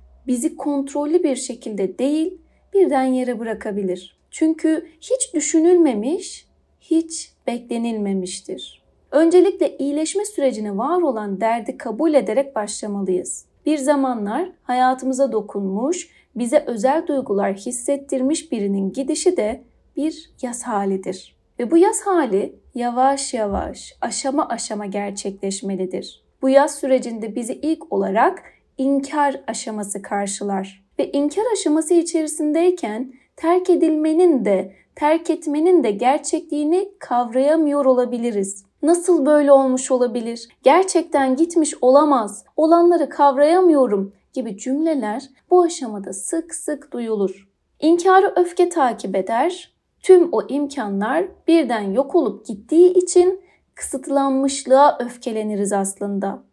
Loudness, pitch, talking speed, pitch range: -19 LUFS, 275 Hz, 105 wpm, 220-325 Hz